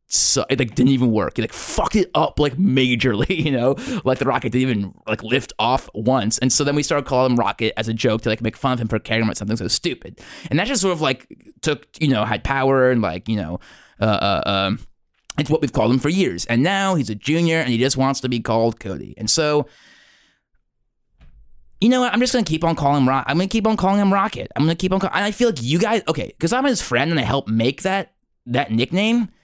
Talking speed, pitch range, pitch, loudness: 260 wpm, 115-165 Hz, 135 Hz, -19 LUFS